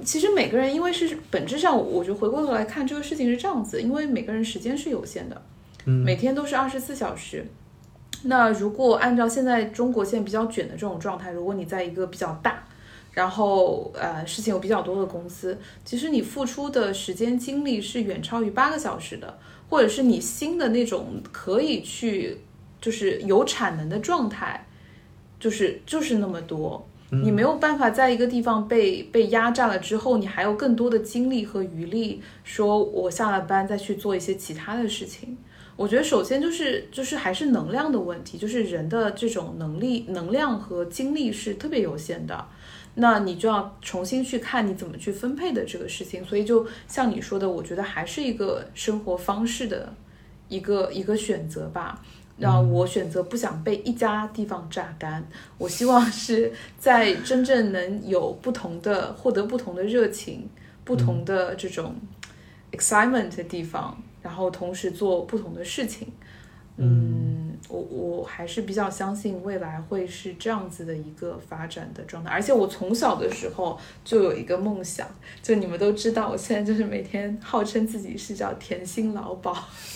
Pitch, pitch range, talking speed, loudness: 210 Hz, 185-245 Hz, 280 characters per minute, -25 LUFS